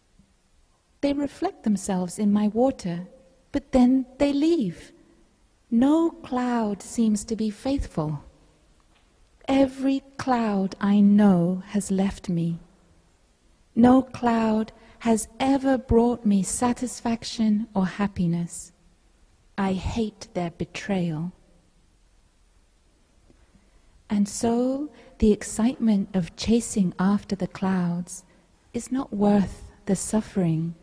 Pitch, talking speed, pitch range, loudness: 210 Hz, 95 wpm, 185-250 Hz, -24 LUFS